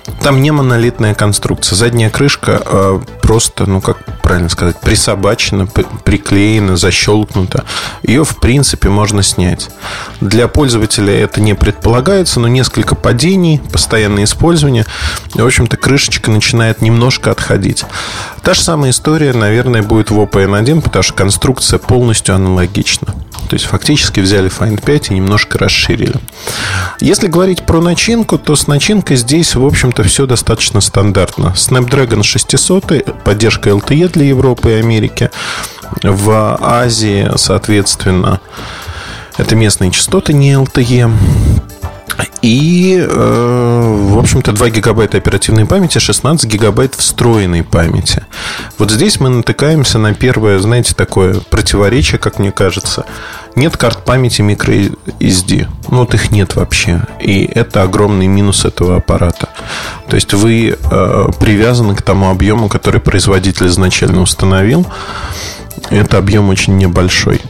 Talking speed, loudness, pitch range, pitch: 130 wpm, -10 LUFS, 100-125 Hz, 110 Hz